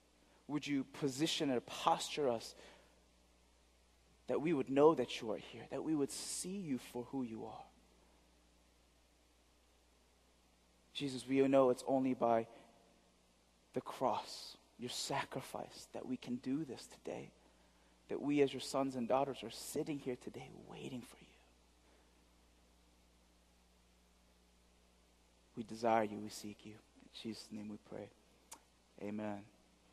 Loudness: -39 LUFS